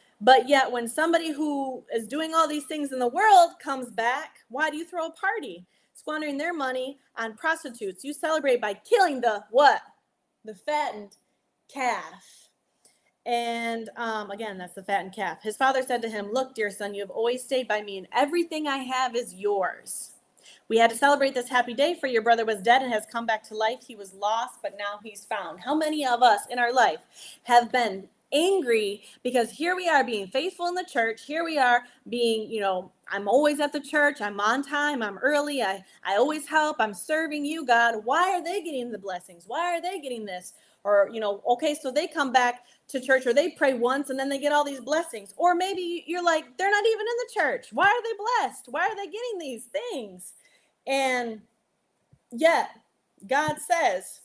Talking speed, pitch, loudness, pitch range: 205 wpm, 260 Hz, -25 LUFS, 225-310 Hz